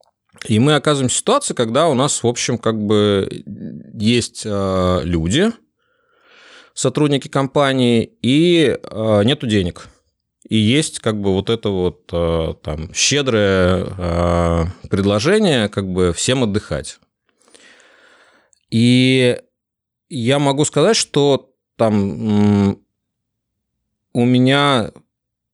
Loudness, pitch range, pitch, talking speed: -16 LUFS, 100-135 Hz, 115 Hz, 95 wpm